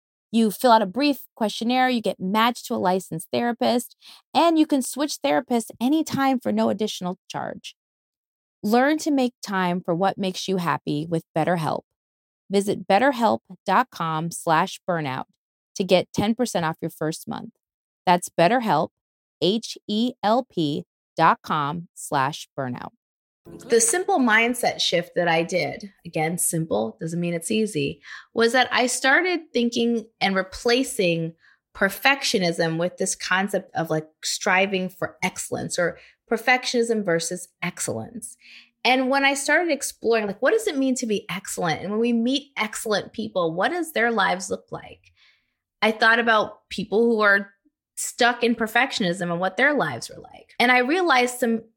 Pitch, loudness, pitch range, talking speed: 215 Hz, -22 LUFS, 180-245 Hz, 145 wpm